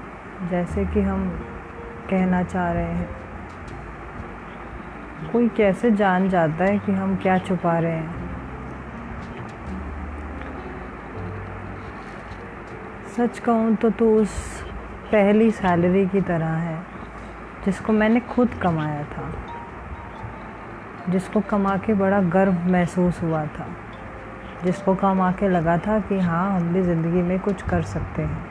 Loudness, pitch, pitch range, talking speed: -22 LUFS, 180 Hz, 150-195 Hz, 120 wpm